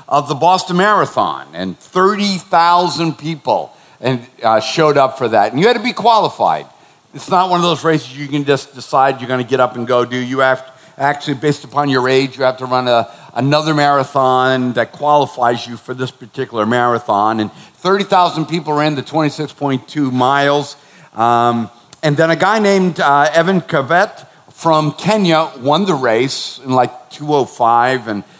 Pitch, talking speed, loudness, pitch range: 140 Hz, 190 wpm, -14 LUFS, 125-160 Hz